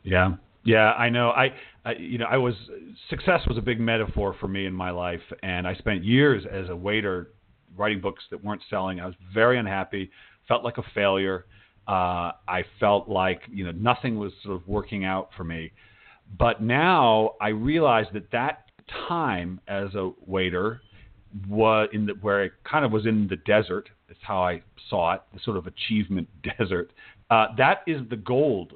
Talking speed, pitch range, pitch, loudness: 190 wpm, 95-110 Hz, 100 Hz, -25 LUFS